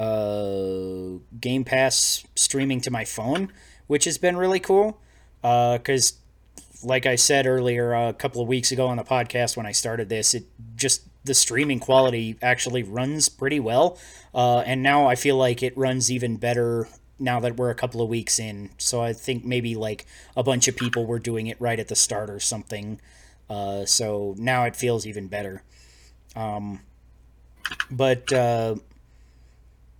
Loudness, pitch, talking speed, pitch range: -23 LUFS, 120 Hz, 170 wpm, 105-130 Hz